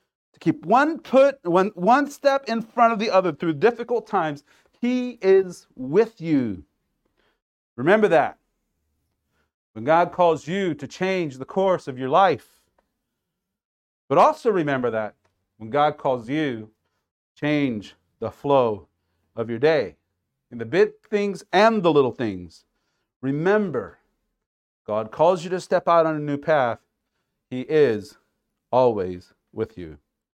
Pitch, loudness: 155 Hz, -22 LUFS